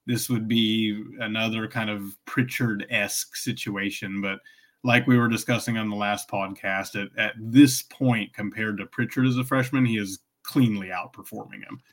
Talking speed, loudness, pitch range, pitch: 165 wpm, -25 LUFS, 105-125 Hz, 110 Hz